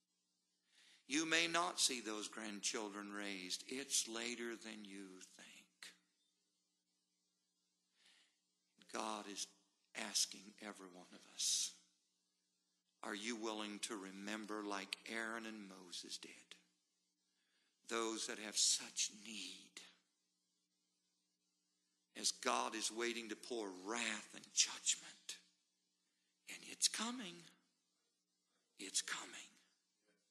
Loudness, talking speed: -42 LUFS, 95 wpm